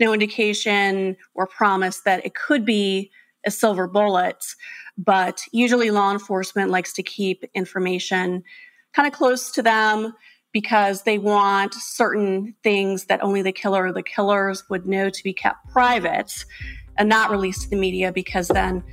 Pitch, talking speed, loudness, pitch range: 200 Hz, 160 wpm, -21 LUFS, 190-220 Hz